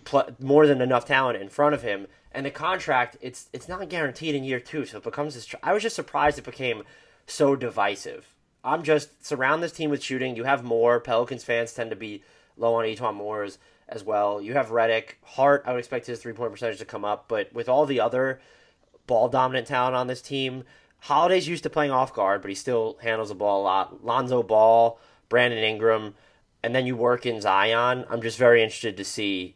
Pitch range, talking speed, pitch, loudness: 115-145 Hz, 220 wpm, 125 Hz, -24 LUFS